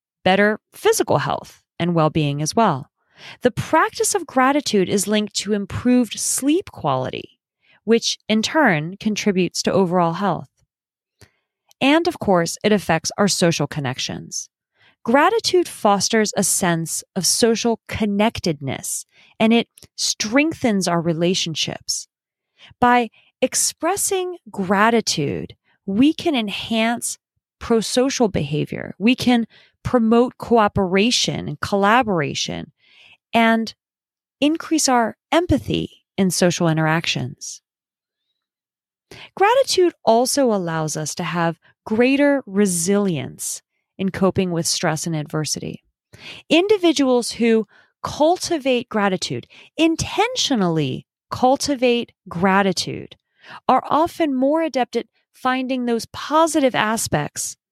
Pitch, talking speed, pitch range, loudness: 220 Hz, 100 wpm, 185-260 Hz, -19 LUFS